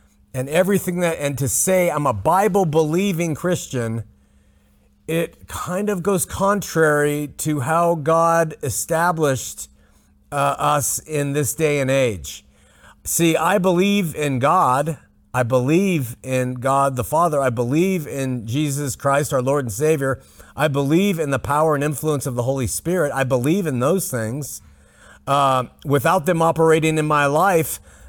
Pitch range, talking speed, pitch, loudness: 130-165 Hz, 150 wpm, 150 Hz, -19 LUFS